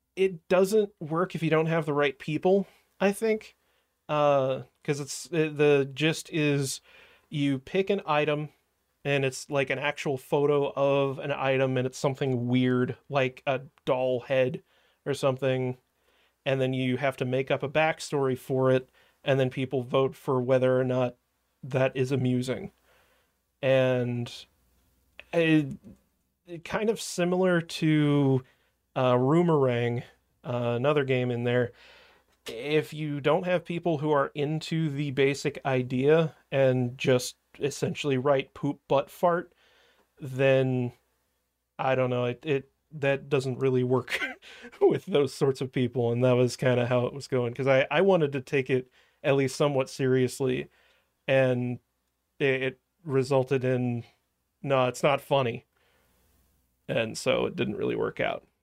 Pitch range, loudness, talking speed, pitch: 125-150 Hz, -27 LUFS, 150 wpm, 135 Hz